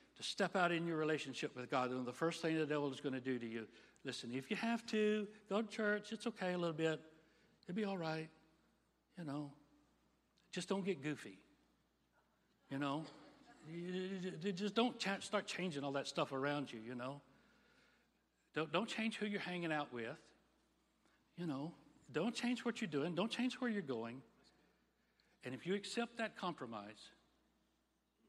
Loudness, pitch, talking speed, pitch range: -42 LUFS, 165 Hz, 175 wpm, 140-210 Hz